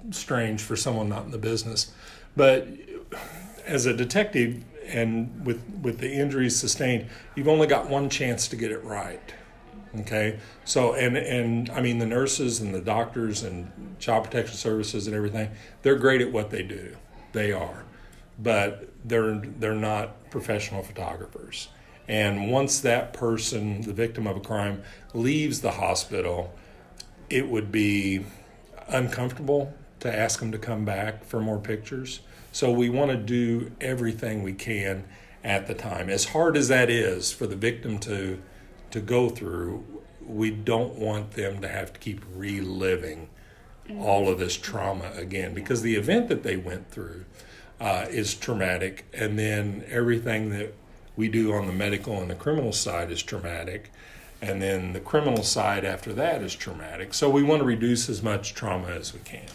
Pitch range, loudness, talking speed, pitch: 100-120 Hz, -27 LUFS, 165 wpm, 110 Hz